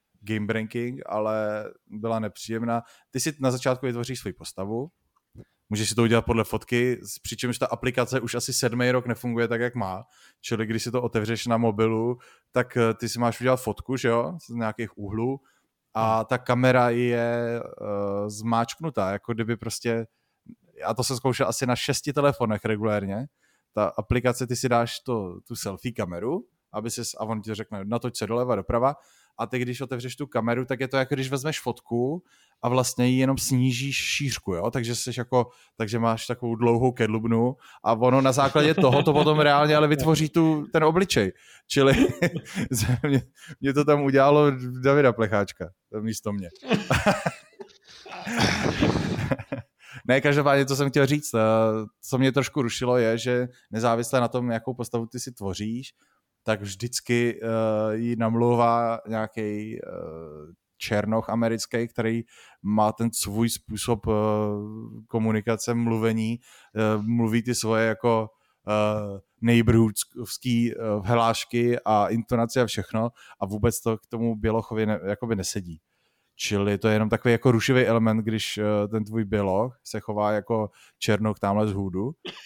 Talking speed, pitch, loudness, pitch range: 155 wpm, 115 Hz, -25 LUFS, 110-125 Hz